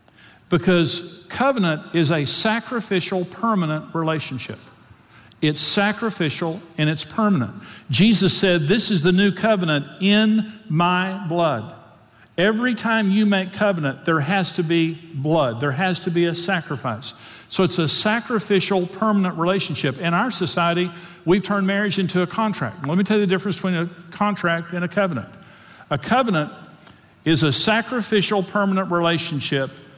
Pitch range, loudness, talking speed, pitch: 160-200 Hz, -20 LUFS, 145 wpm, 180 Hz